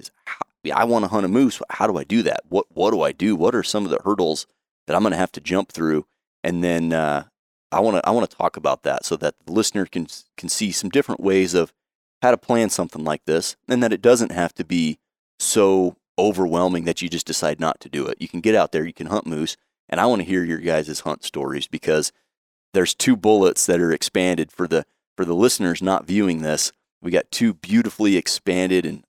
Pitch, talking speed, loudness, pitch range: 90 Hz, 240 wpm, -21 LUFS, 85-110 Hz